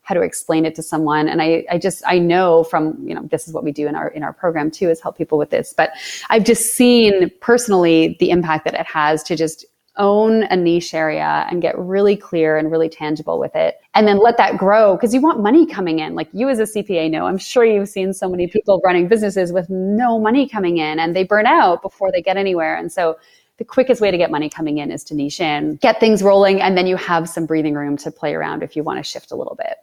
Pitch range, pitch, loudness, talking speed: 160-205 Hz, 180 Hz, -16 LUFS, 260 wpm